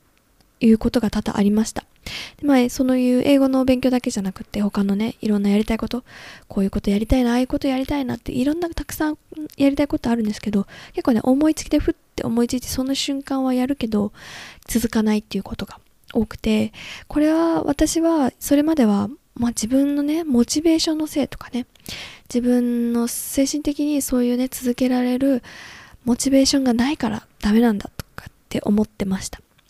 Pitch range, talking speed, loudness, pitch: 225-280 Hz, 405 characters per minute, -20 LUFS, 250 Hz